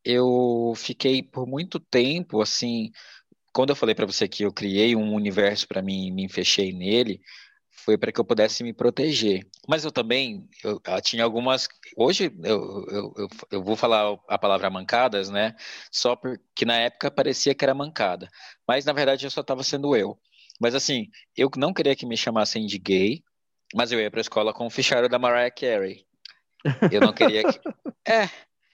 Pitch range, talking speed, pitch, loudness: 105-130 Hz, 185 wpm, 115 Hz, -24 LUFS